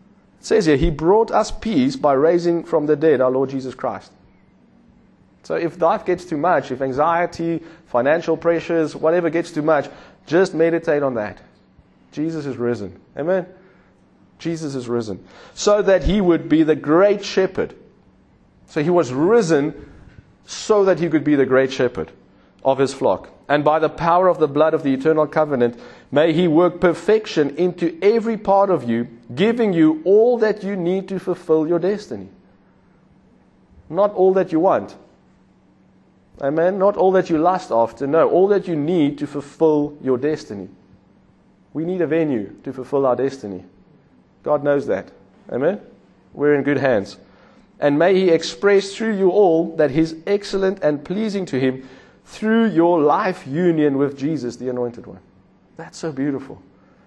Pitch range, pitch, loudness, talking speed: 140-180 Hz, 160 Hz, -19 LUFS, 165 wpm